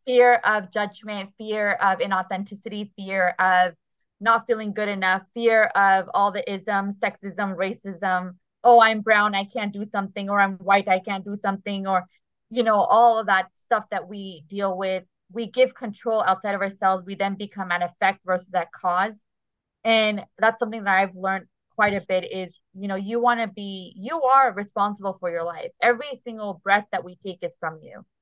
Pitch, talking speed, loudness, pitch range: 200 Hz, 185 wpm, -23 LUFS, 190-220 Hz